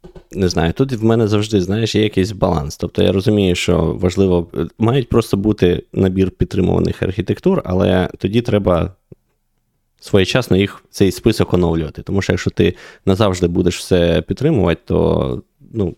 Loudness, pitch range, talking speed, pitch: -16 LUFS, 90-105 Hz, 145 wpm, 95 Hz